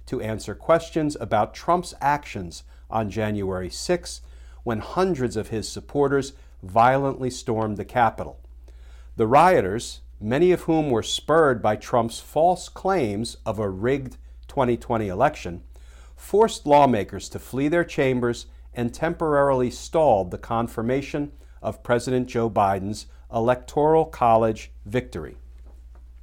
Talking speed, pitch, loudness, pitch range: 120 wpm, 115 Hz, -23 LUFS, 85-135 Hz